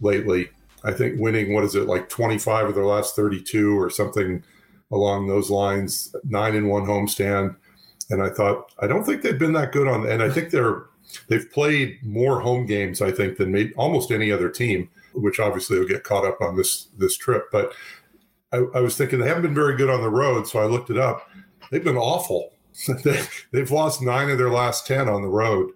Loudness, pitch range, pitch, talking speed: -22 LUFS, 100-140 Hz, 115 Hz, 205 wpm